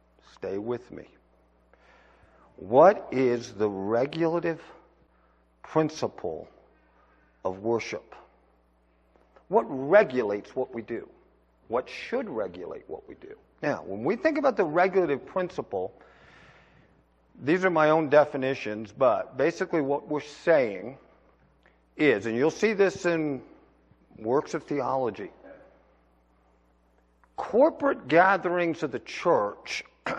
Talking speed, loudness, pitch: 105 wpm, -26 LUFS, 130 Hz